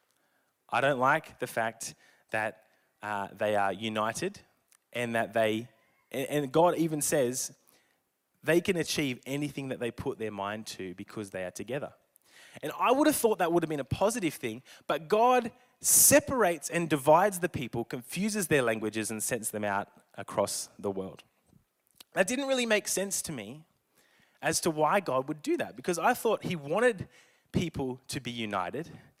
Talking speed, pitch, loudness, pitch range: 175 wpm, 140 Hz, -29 LUFS, 110-180 Hz